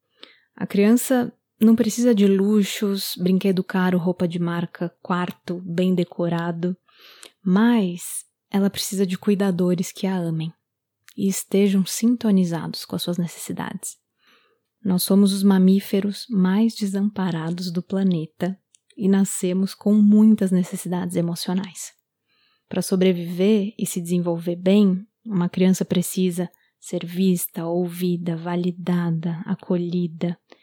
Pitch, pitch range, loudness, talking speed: 185 Hz, 175-200 Hz, -22 LUFS, 110 wpm